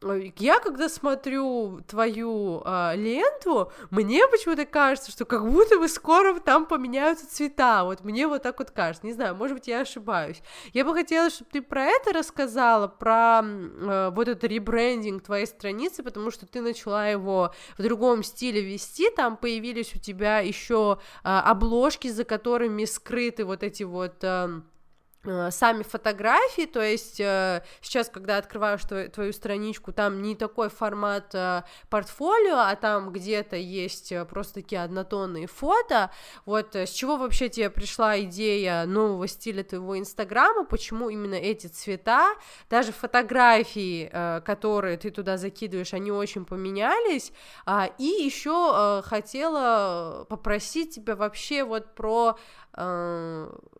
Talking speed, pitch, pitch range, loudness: 135 wpm, 220 Hz, 195-250 Hz, -25 LUFS